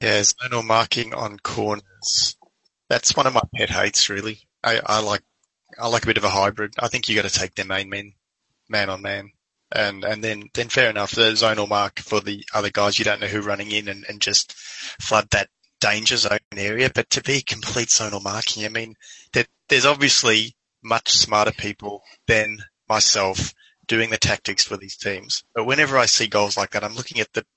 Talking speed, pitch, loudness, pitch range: 205 wpm, 105 Hz, -20 LUFS, 100-115 Hz